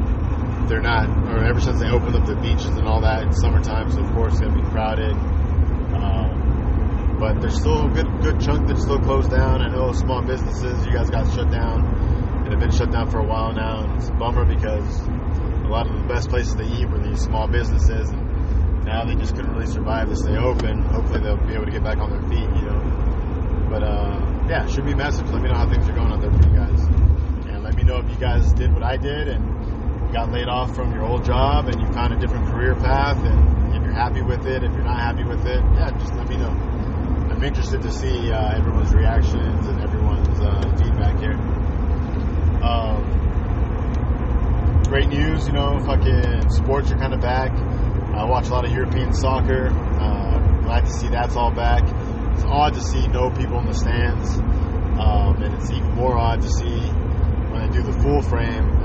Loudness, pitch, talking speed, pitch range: -21 LUFS, 80 Hz, 215 wpm, 75-85 Hz